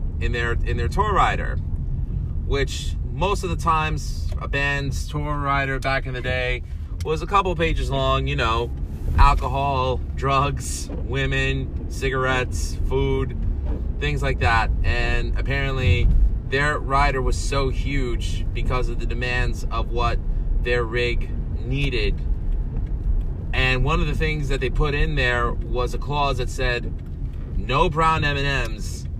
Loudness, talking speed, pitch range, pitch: -23 LUFS, 145 wpm, 80-130 Hz, 105 Hz